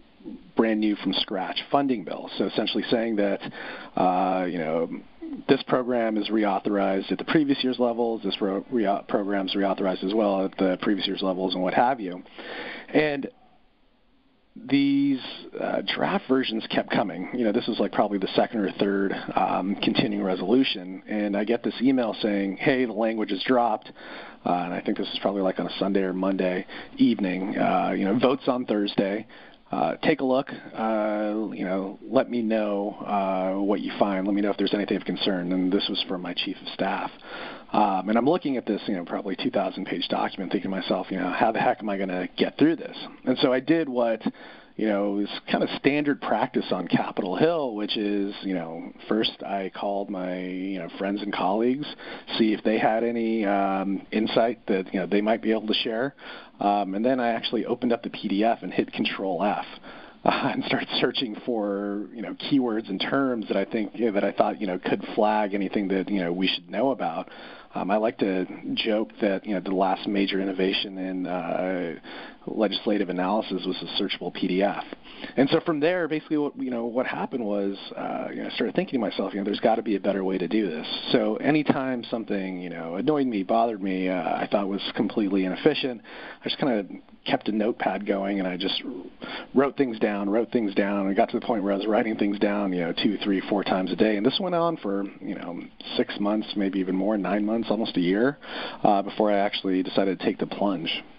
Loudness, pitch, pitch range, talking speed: -26 LUFS, 105 Hz, 95-120 Hz, 215 wpm